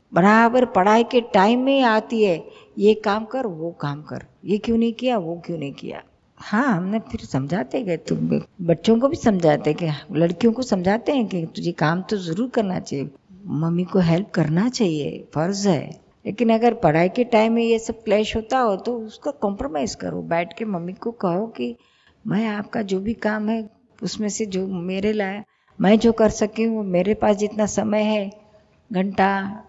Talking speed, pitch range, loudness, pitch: 190 wpm, 180-225 Hz, -21 LUFS, 210 Hz